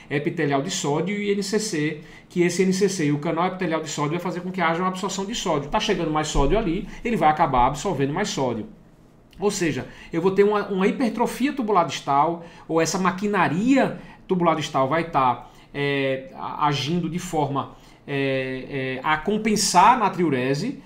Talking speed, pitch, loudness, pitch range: 180 wpm, 165 Hz, -23 LUFS, 145-195 Hz